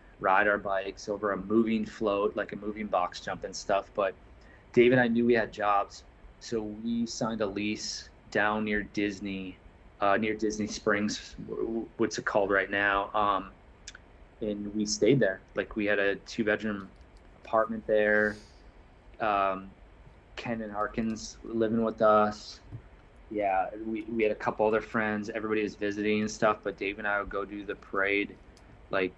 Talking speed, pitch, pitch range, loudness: 170 wpm, 105 Hz, 100-110 Hz, -29 LUFS